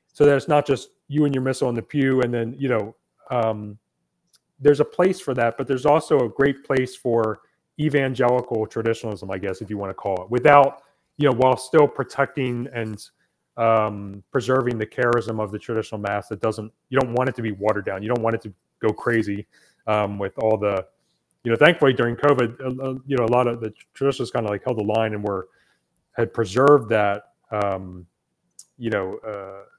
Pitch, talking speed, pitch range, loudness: 120 Hz, 210 wpm, 105-135 Hz, -22 LUFS